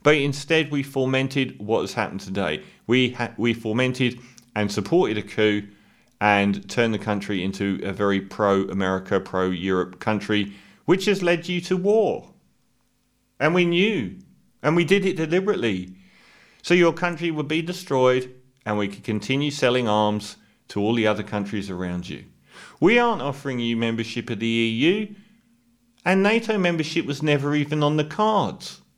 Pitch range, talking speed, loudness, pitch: 105-165 Hz, 160 wpm, -23 LUFS, 125 Hz